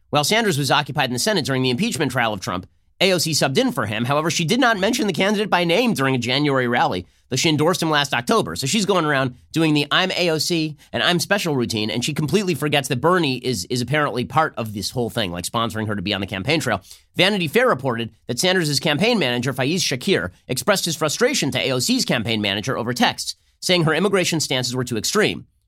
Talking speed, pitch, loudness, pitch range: 225 wpm, 145 Hz, -20 LUFS, 120-175 Hz